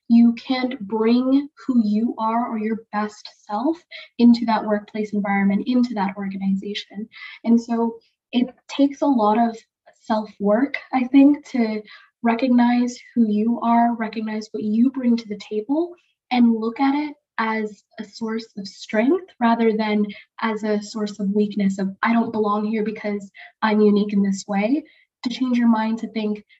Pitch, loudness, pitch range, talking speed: 225 Hz, -21 LUFS, 210-245 Hz, 165 wpm